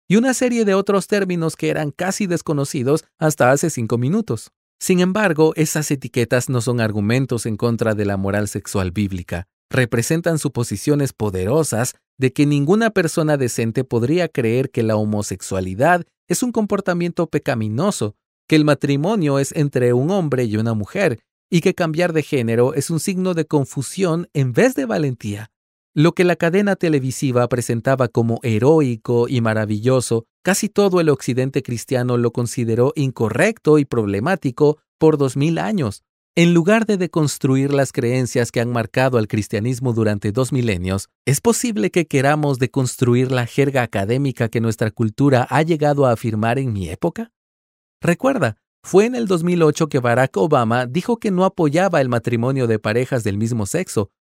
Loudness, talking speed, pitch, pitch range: -19 LUFS, 160 wpm, 135 Hz, 120-165 Hz